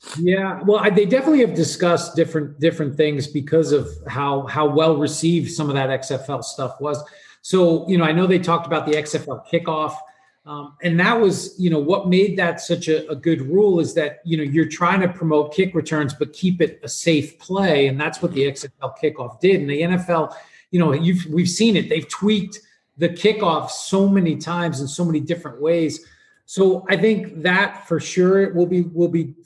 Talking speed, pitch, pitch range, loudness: 205 wpm, 165 Hz, 150-185 Hz, -19 LUFS